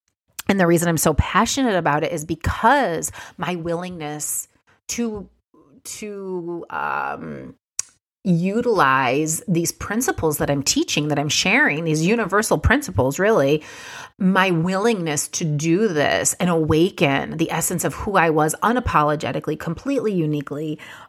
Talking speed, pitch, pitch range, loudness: 125 wpm, 170 Hz, 155-205 Hz, -20 LUFS